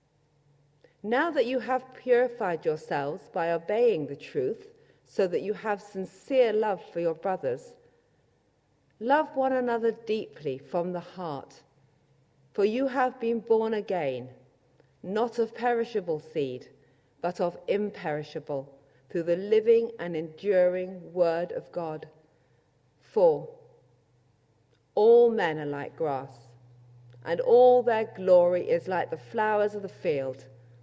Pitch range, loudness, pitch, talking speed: 145-230 Hz, -27 LUFS, 180 Hz, 125 wpm